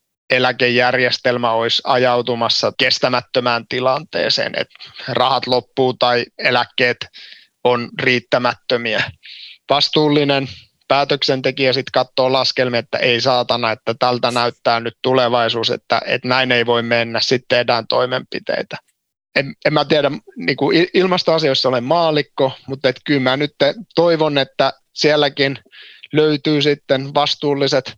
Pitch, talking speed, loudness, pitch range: 130 Hz, 115 wpm, -16 LUFS, 120-145 Hz